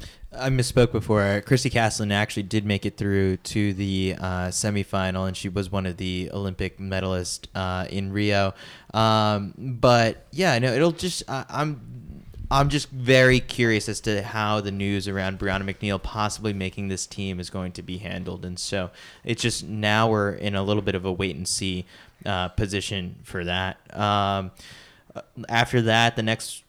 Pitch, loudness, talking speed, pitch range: 100 Hz, -24 LUFS, 180 wpm, 95-110 Hz